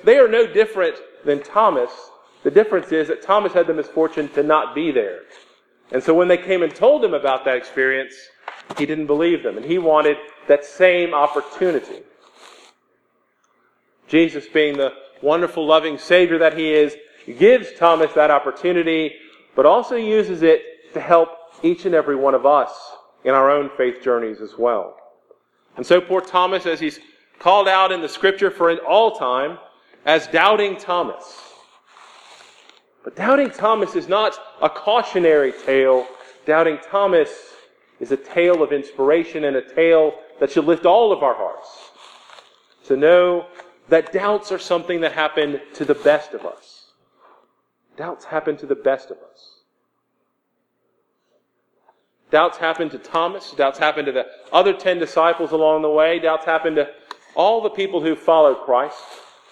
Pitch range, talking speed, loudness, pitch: 150-210 Hz, 160 wpm, -18 LUFS, 165 Hz